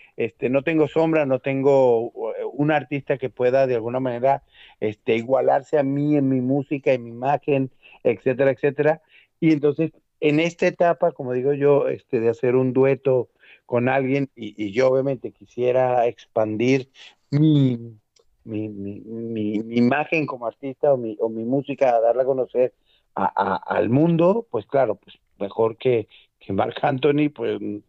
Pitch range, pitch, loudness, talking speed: 120-145 Hz, 135 Hz, -22 LUFS, 165 wpm